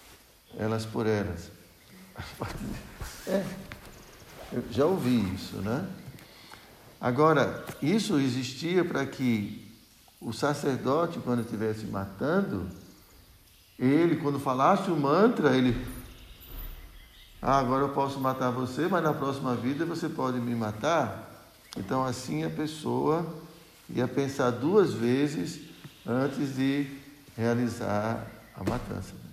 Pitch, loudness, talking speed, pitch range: 125 Hz, -29 LUFS, 105 wpm, 110-145 Hz